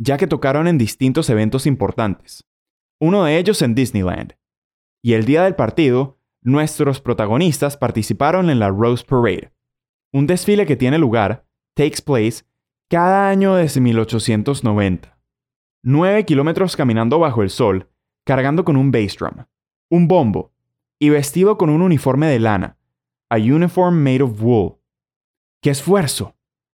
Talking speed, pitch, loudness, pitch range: 140 wpm, 135 Hz, -16 LUFS, 115-160 Hz